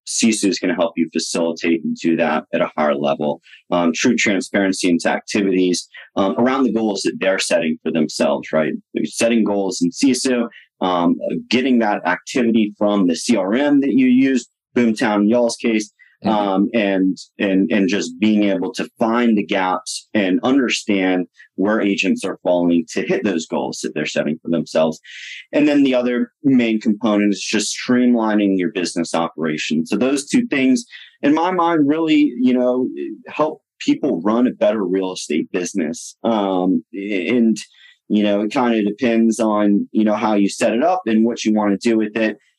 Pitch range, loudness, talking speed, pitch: 95-125 Hz, -18 LUFS, 180 wpm, 110 Hz